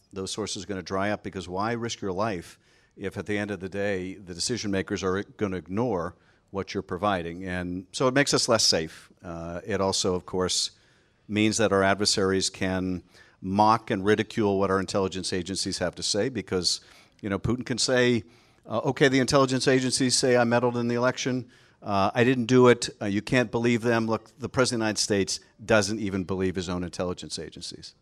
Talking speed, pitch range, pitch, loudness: 210 wpm, 95-120 Hz, 100 Hz, -26 LUFS